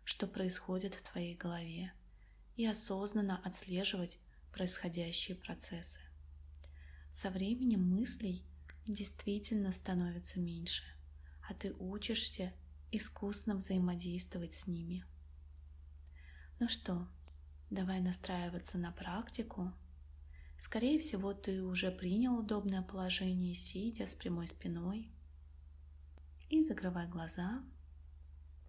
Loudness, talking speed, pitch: -39 LUFS, 90 wpm, 175 Hz